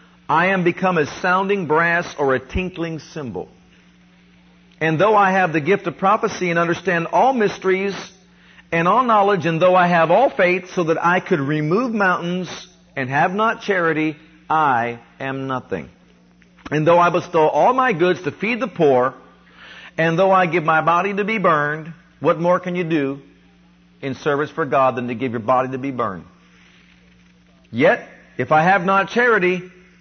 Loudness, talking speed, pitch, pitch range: -18 LUFS, 175 wpm, 170 Hz, 135-185 Hz